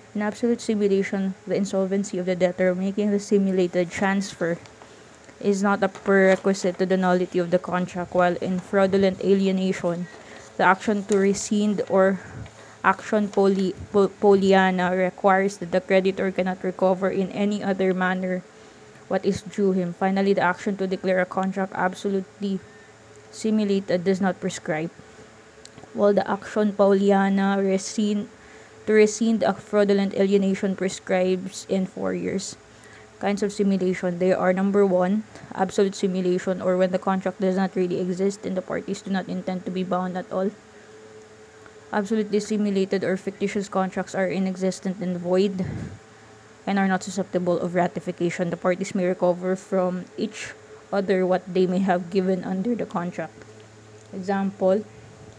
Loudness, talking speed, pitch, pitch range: -23 LUFS, 145 wpm, 190 Hz, 180-195 Hz